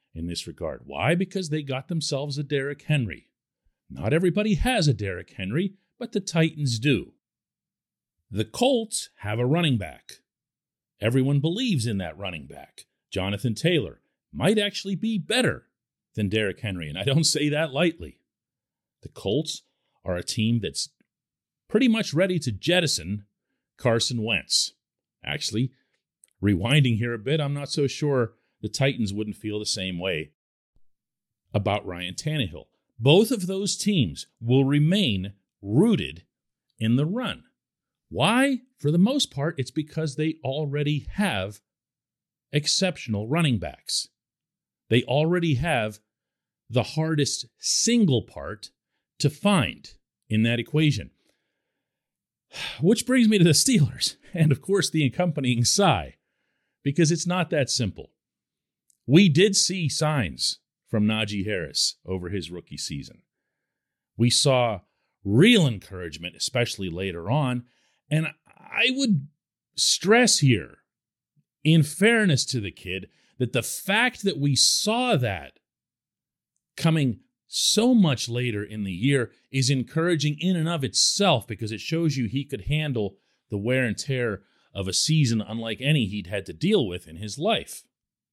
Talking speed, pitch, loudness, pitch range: 140 wpm, 140 Hz, -24 LUFS, 110-165 Hz